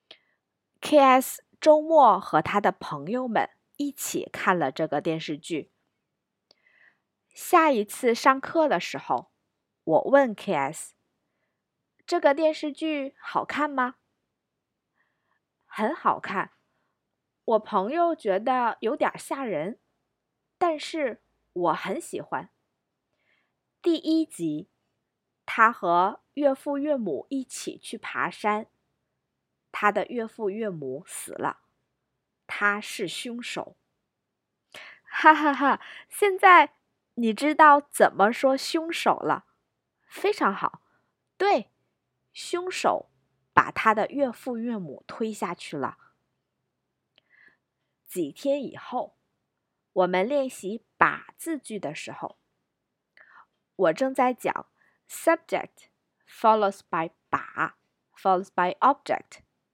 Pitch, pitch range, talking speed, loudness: 255 Hz, 200-300 Hz, 165 characters per minute, -25 LUFS